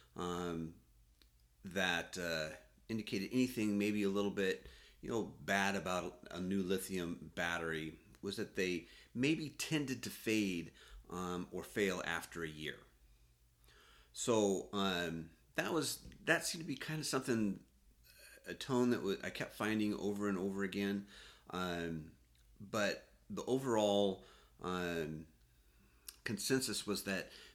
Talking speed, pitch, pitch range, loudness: 135 wpm, 95 Hz, 80-105 Hz, -39 LUFS